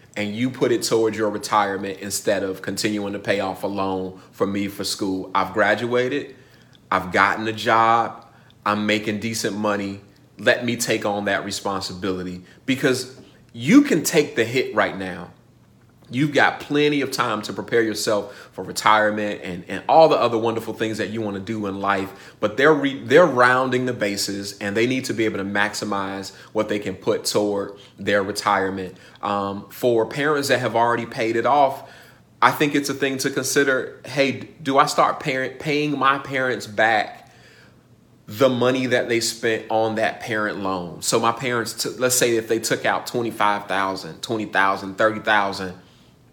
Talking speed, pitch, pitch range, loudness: 175 wpm, 110 Hz, 100-125 Hz, -21 LUFS